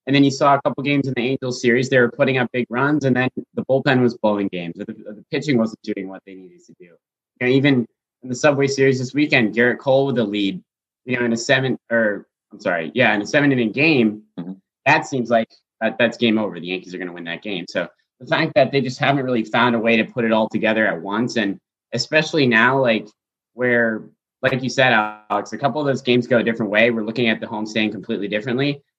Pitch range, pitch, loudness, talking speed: 110-135 Hz, 120 Hz, -19 LUFS, 240 wpm